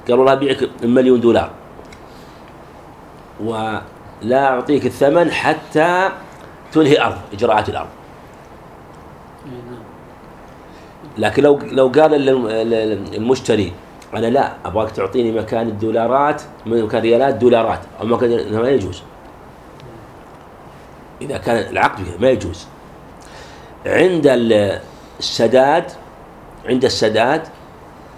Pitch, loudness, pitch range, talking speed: 115 Hz, -16 LUFS, 105-135 Hz, 85 wpm